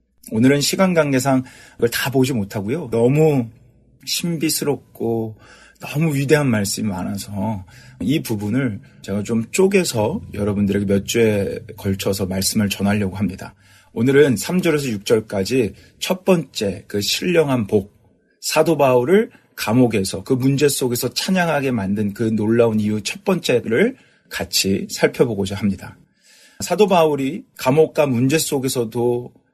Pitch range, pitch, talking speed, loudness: 105-145 Hz, 120 Hz, 280 characters per minute, -19 LUFS